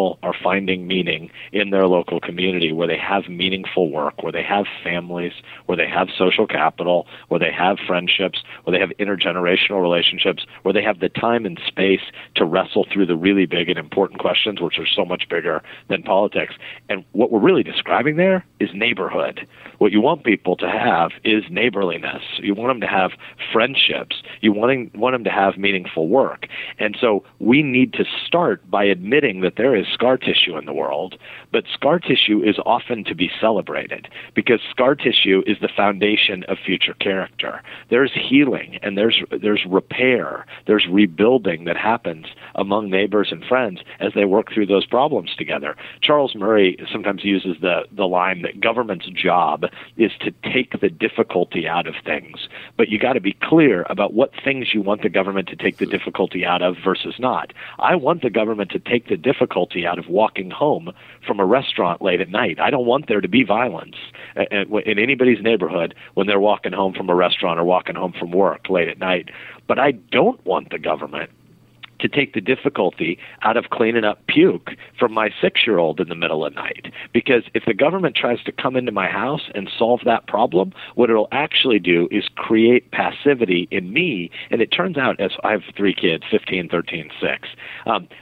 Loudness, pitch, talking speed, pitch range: -19 LUFS, 100 Hz, 190 wpm, 90-110 Hz